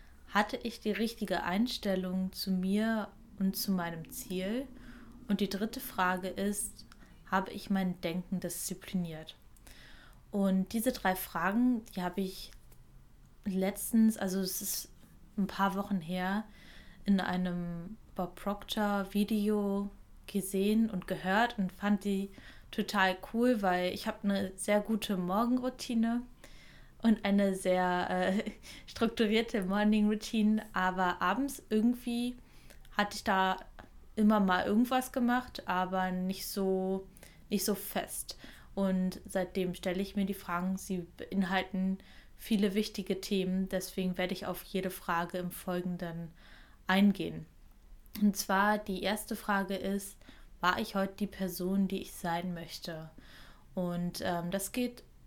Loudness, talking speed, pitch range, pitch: -33 LUFS, 130 wpm, 185-215 Hz, 195 Hz